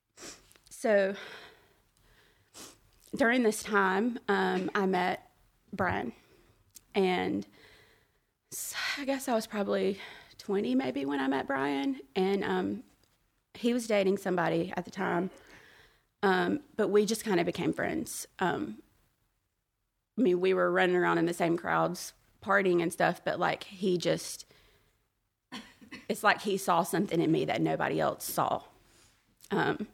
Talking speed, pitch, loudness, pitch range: 135 wpm, 190 Hz, -30 LUFS, 170-205 Hz